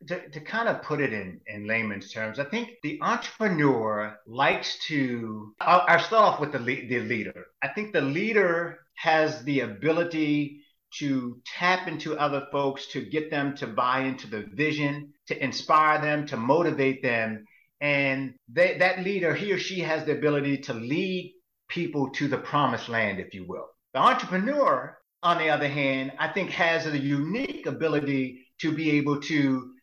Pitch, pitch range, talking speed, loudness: 145 Hz, 135-170 Hz, 175 wpm, -26 LUFS